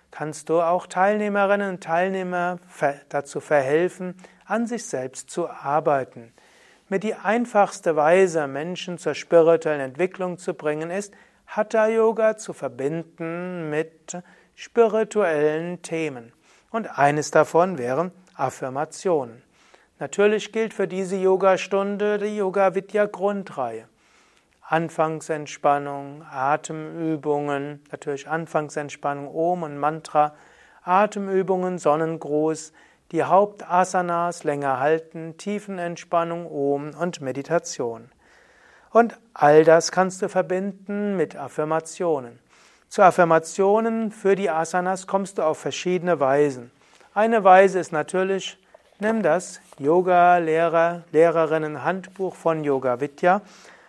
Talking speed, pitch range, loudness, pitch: 100 wpm, 150-190 Hz, -22 LUFS, 170 Hz